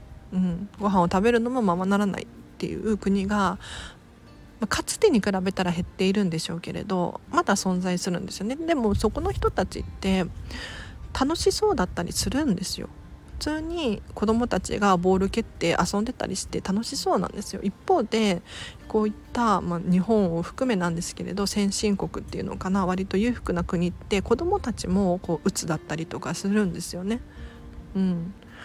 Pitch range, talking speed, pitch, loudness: 180-225 Hz, 330 characters per minute, 195 Hz, -26 LUFS